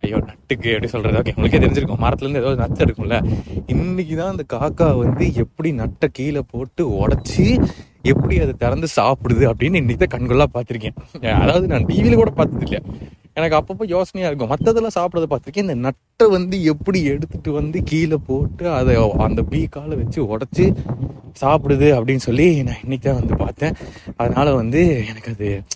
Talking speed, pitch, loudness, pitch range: 150 wpm, 140 Hz, -18 LUFS, 120-165 Hz